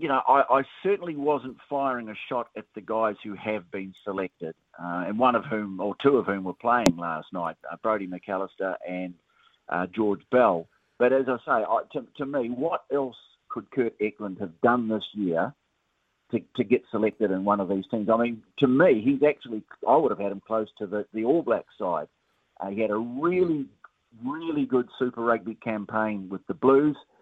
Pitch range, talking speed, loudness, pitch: 100-125 Hz, 205 wpm, -26 LUFS, 110 Hz